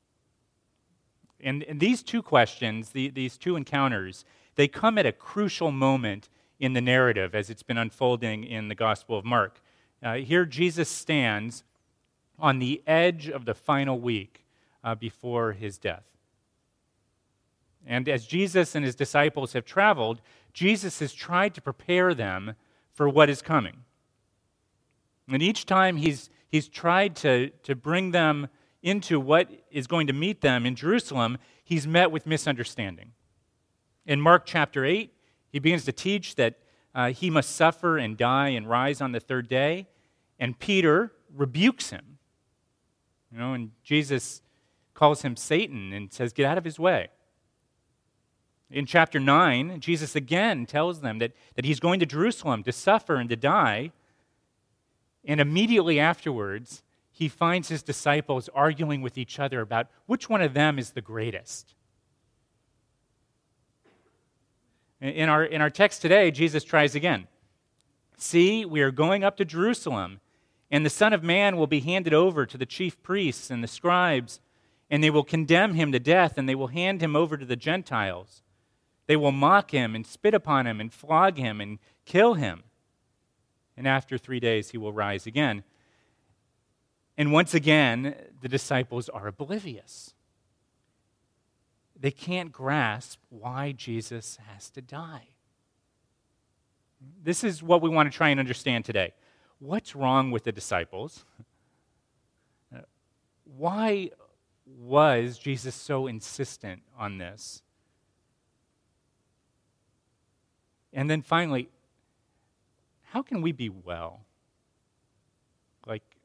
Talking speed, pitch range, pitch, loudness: 140 wpm, 115-160 Hz, 135 Hz, -25 LUFS